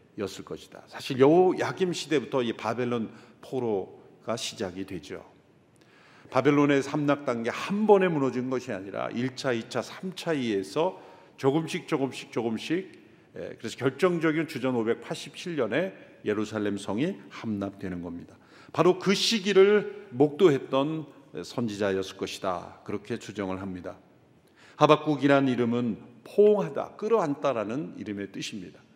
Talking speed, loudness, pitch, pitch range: 285 characters per minute, -27 LUFS, 135 Hz, 110-160 Hz